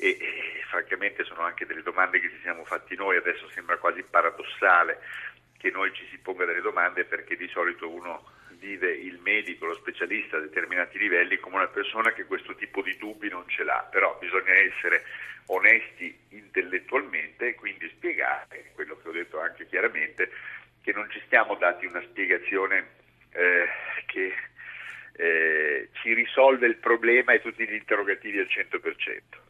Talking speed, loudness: 165 wpm, -25 LUFS